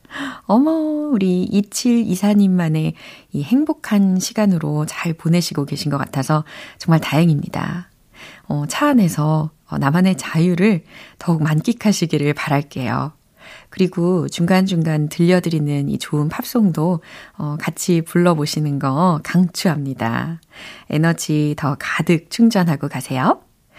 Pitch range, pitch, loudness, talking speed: 150-195 Hz, 170 Hz, -18 LUFS, 265 characters per minute